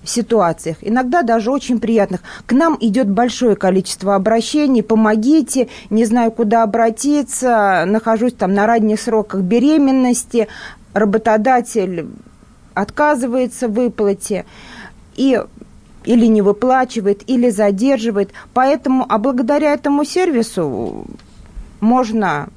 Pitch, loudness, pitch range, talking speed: 230 Hz, -15 LUFS, 215-255 Hz, 105 wpm